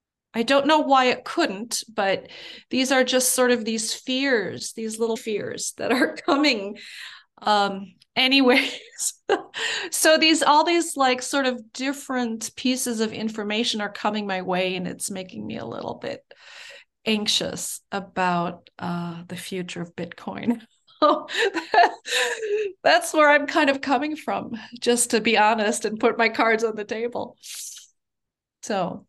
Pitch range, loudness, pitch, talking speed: 210-280 Hz, -22 LUFS, 235 Hz, 145 wpm